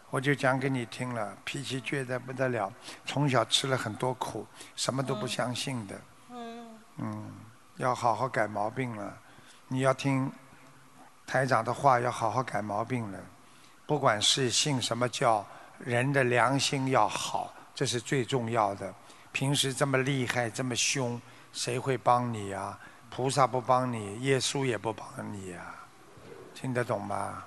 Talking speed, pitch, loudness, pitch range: 220 characters per minute, 125 Hz, -30 LUFS, 115-135 Hz